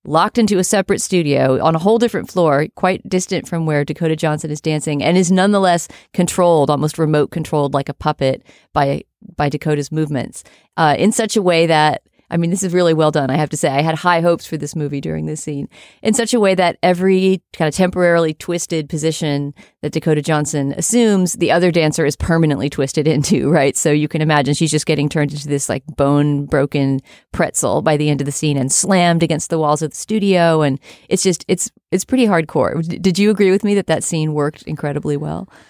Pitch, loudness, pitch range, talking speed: 160 Hz, -16 LUFS, 150-185 Hz, 215 wpm